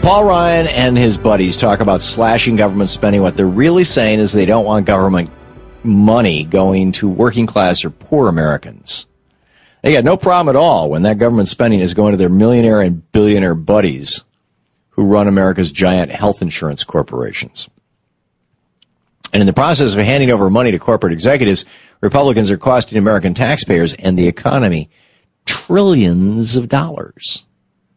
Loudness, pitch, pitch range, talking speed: -12 LUFS, 105 Hz, 95-120 Hz, 160 wpm